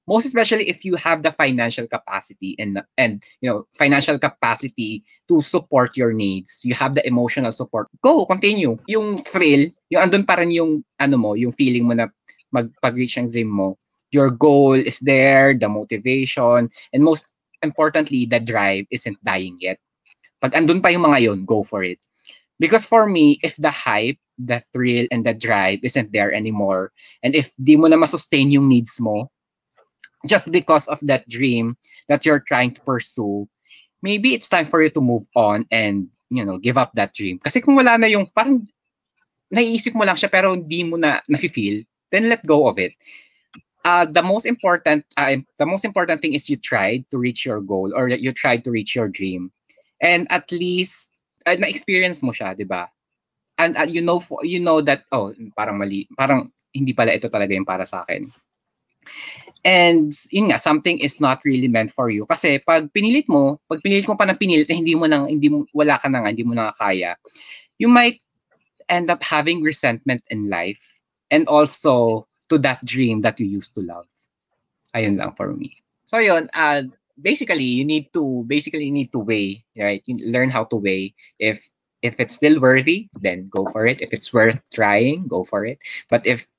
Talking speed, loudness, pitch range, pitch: 185 wpm, -18 LUFS, 115-170 Hz, 135 Hz